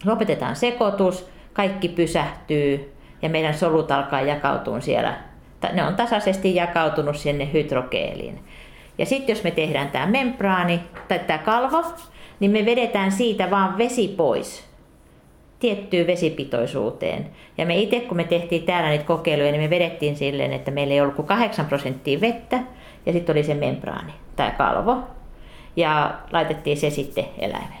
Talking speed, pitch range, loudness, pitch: 145 wpm, 145-200 Hz, -22 LUFS, 170 Hz